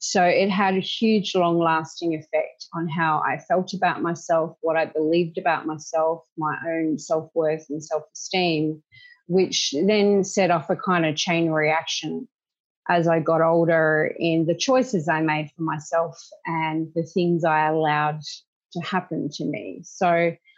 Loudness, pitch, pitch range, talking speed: -23 LUFS, 165 Hz, 155-180 Hz, 165 wpm